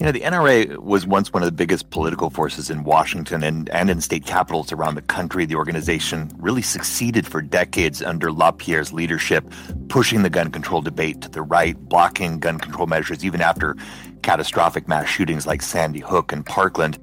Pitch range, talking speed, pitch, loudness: 80-85 Hz, 185 wpm, 80 Hz, -20 LUFS